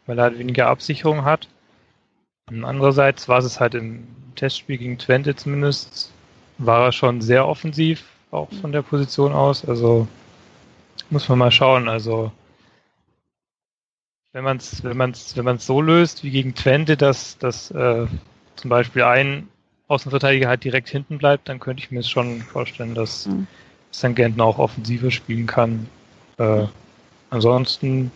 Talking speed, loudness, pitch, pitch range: 145 wpm, -19 LUFS, 125 Hz, 120-140 Hz